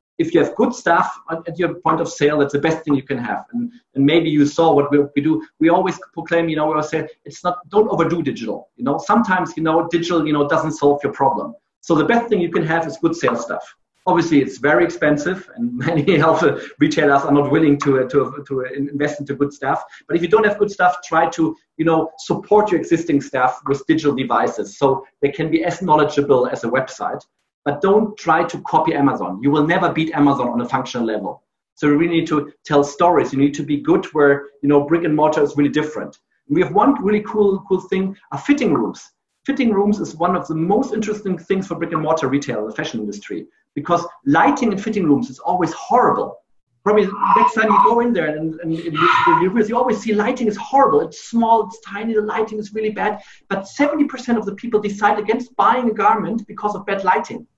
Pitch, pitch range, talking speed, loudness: 165 Hz, 145-210 Hz, 230 wpm, -18 LUFS